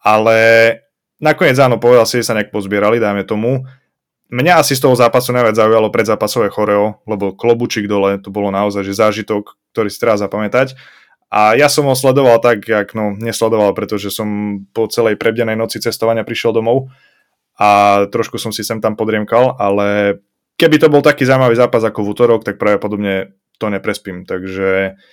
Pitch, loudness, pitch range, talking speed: 110 Hz, -13 LUFS, 105-120 Hz, 170 wpm